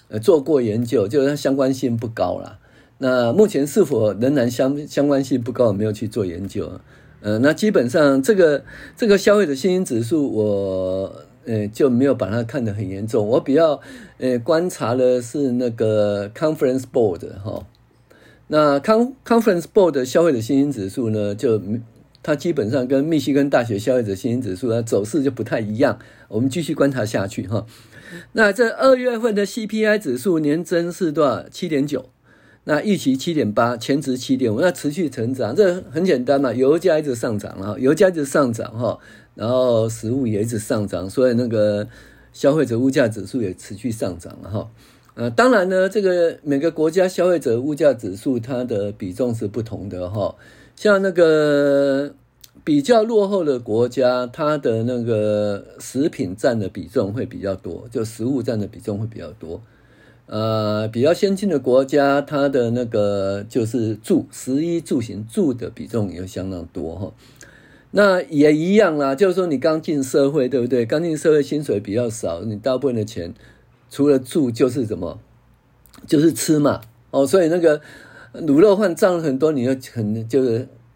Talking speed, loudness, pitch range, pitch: 280 characters per minute, -19 LUFS, 110-150 Hz, 130 Hz